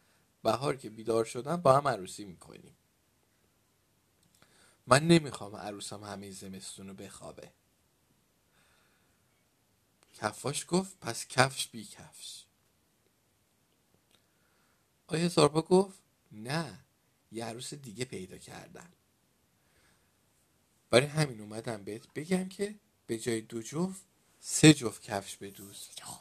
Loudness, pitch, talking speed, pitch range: -31 LUFS, 115 Hz, 105 wpm, 105-155 Hz